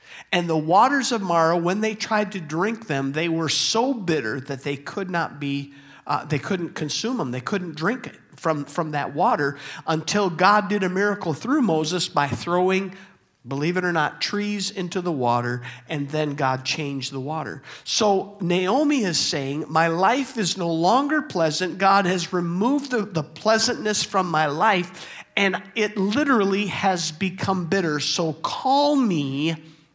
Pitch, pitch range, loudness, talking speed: 175 Hz, 155-205 Hz, -23 LUFS, 170 wpm